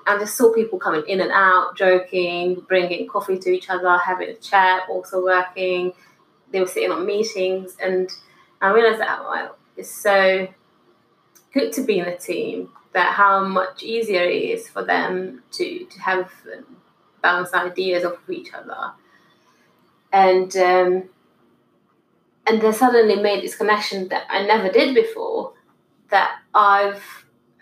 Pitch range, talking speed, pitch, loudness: 185-210 Hz, 150 wpm, 190 Hz, -19 LUFS